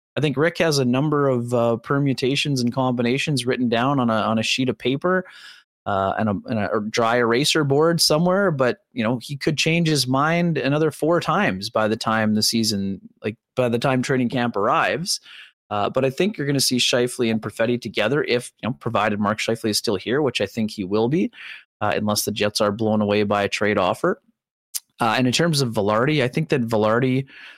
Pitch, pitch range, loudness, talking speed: 125 Hz, 110-145 Hz, -21 LUFS, 220 wpm